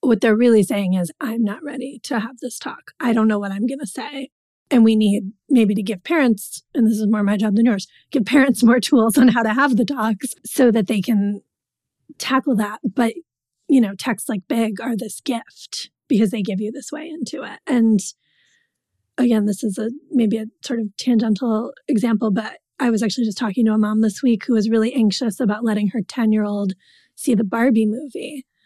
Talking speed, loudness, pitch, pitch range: 220 wpm, -19 LUFS, 230 Hz, 215-255 Hz